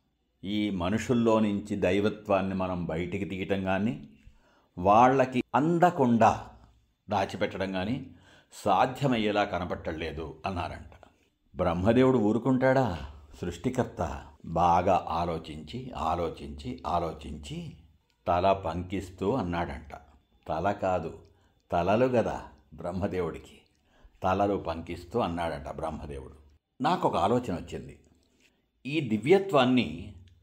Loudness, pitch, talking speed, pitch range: -28 LUFS, 95 Hz, 80 wpm, 85-110 Hz